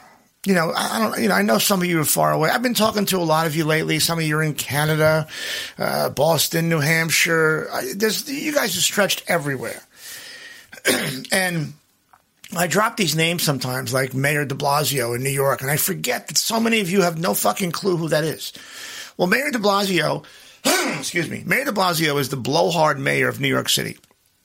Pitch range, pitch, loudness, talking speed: 150-200 Hz, 165 Hz, -20 LUFS, 210 wpm